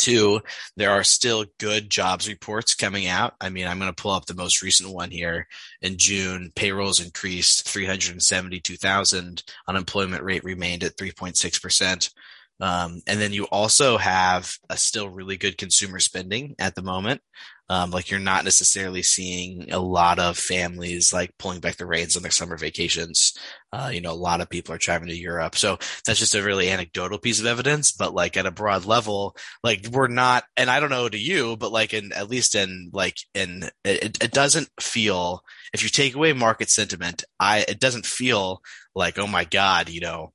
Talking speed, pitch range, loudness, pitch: 190 wpm, 90-105 Hz, -22 LUFS, 95 Hz